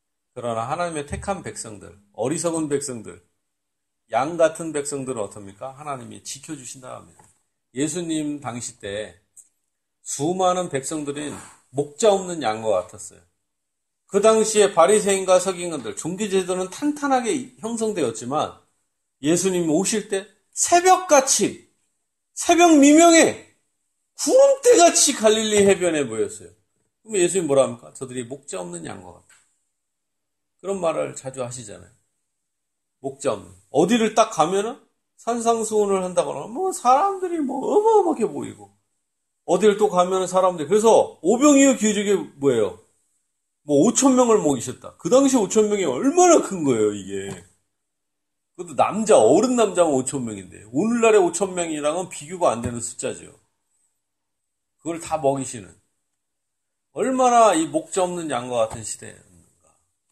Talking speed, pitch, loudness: 290 characters per minute, 175 Hz, -20 LUFS